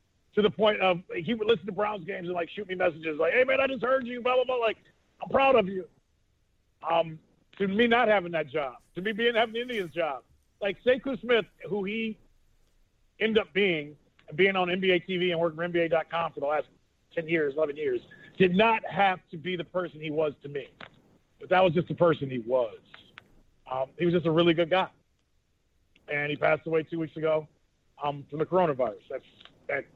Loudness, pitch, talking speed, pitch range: -27 LUFS, 180 Hz, 215 wpm, 160-220 Hz